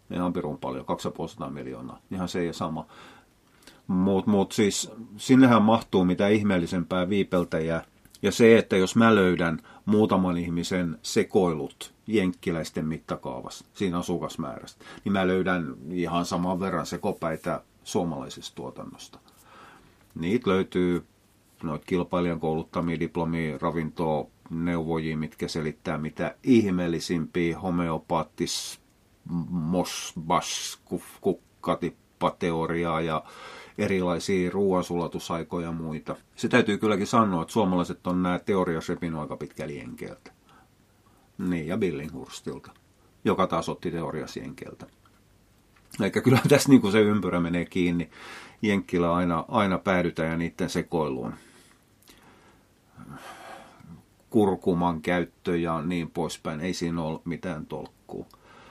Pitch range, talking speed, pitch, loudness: 85-95 Hz, 105 wpm, 90 Hz, -26 LUFS